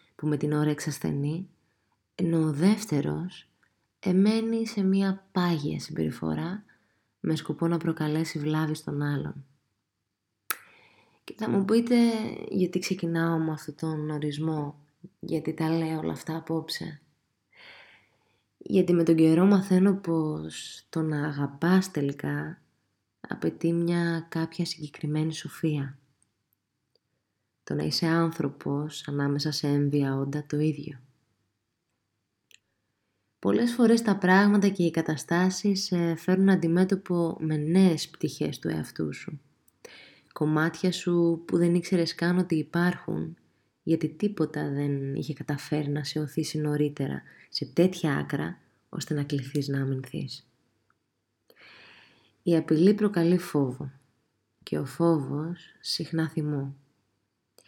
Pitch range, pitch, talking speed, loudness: 140-170 Hz, 155 Hz, 115 wpm, -27 LUFS